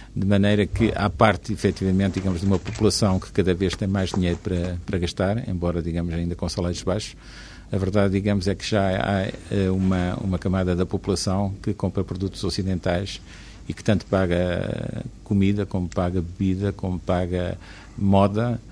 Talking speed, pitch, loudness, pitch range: 165 wpm, 95 Hz, -24 LUFS, 90-100 Hz